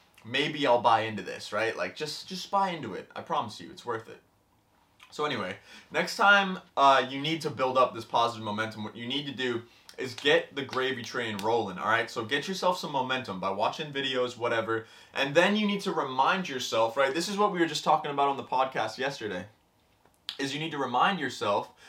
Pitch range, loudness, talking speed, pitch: 120-165 Hz, -28 LUFS, 215 wpm, 140 Hz